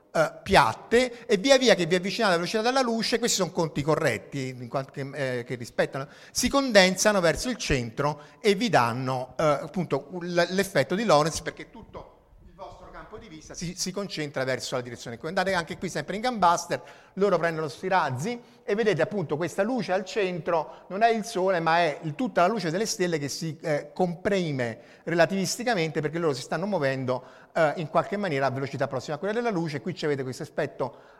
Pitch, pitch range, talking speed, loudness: 170 Hz, 145-195 Hz, 190 wpm, -26 LUFS